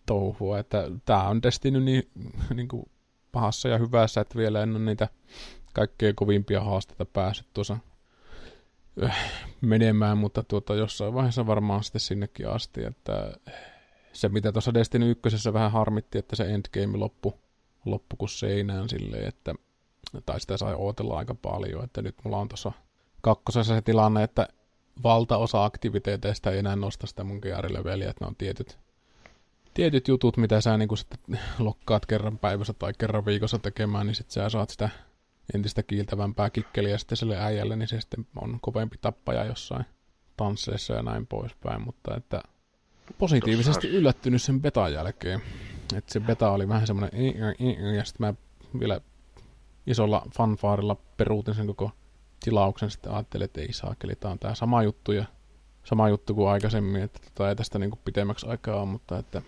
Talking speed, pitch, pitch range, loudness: 160 wpm, 105 Hz, 100-115 Hz, -28 LUFS